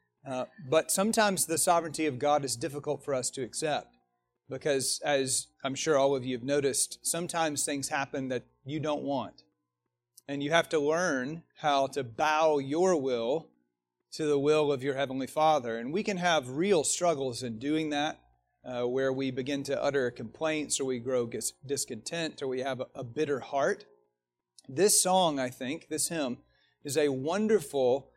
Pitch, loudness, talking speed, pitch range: 140 Hz, -30 LUFS, 175 wpm, 125-155 Hz